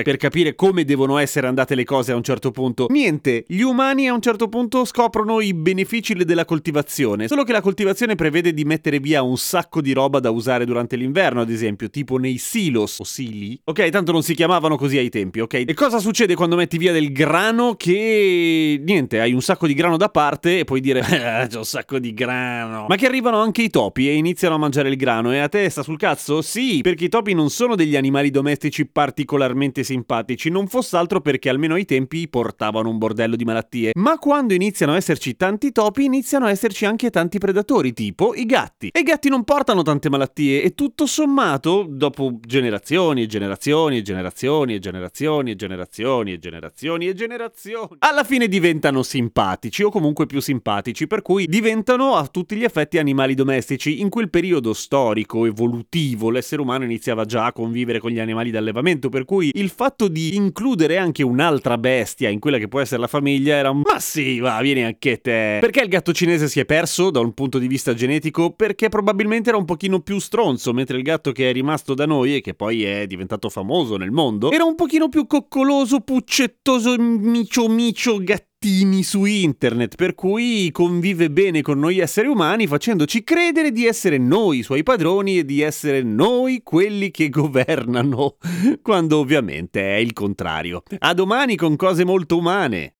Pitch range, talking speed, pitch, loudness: 130-200 Hz, 195 wpm, 155 Hz, -19 LUFS